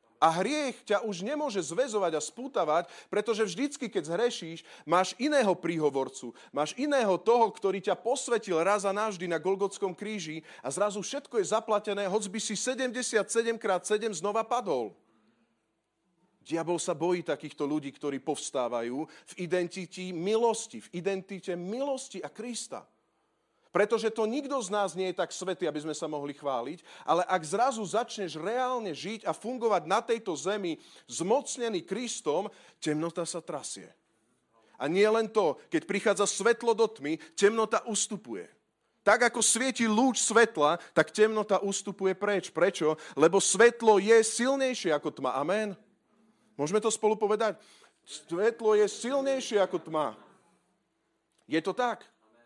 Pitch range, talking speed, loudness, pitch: 175-230 Hz, 145 wpm, -29 LUFS, 205 Hz